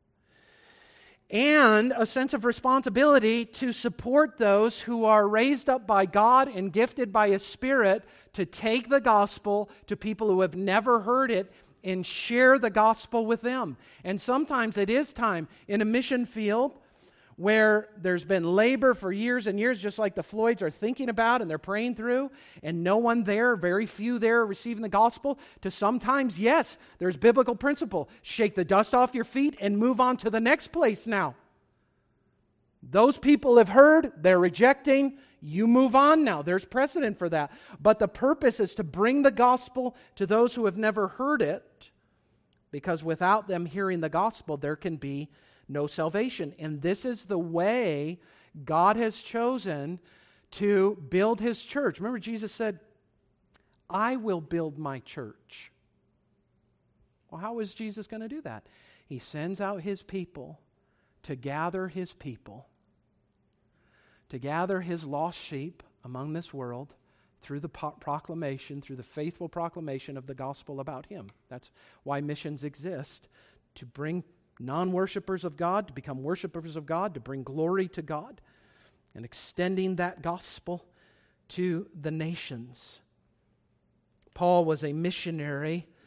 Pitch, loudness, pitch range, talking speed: 200 Hz, -26 LUFS, 160-235 Hz, 155 wpm